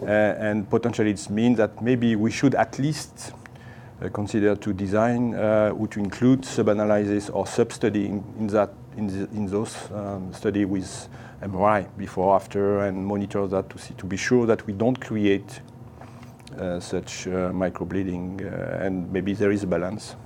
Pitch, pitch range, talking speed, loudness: 105 Hz, 100-120 Hz, 165 wpm, -24 LUFS